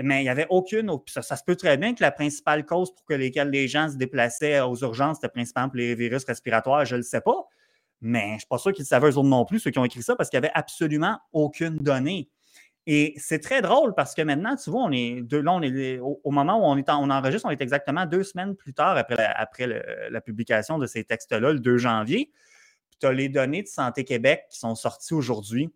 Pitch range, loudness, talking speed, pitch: 125-155 Hz, -24 LUFS, 260 wpm, 140 Hz